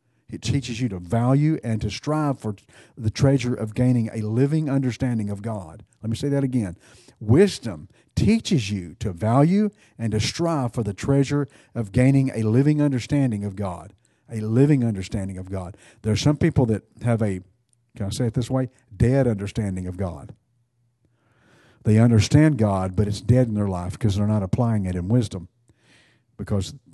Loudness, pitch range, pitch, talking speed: -23 LUFS, 105-130 Hz, 115 Hz, 180 wpm